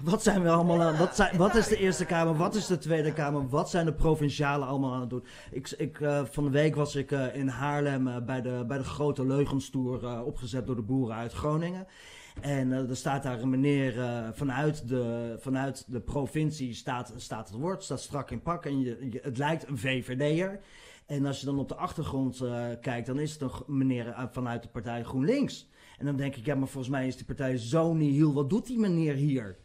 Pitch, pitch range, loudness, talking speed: 140 Hz, 130-155 Hz, -30 LUFS, 235 wpm